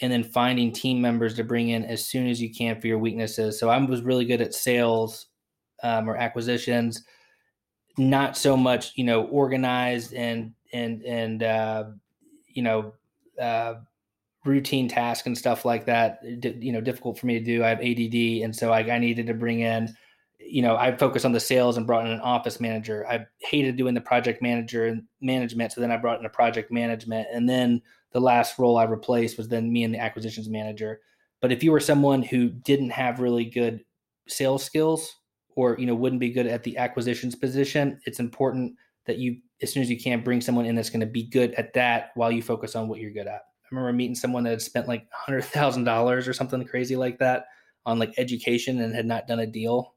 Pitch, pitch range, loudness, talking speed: 120 Hz, 115-125 Hz, -25 LUFS, 215 wpm